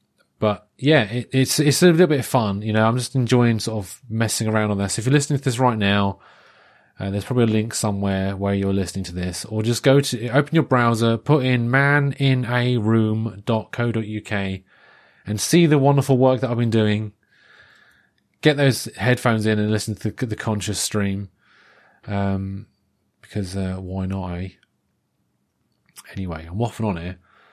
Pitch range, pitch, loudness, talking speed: 100-130 Hz, 110 Hz, -20 LUFS, 175 wpm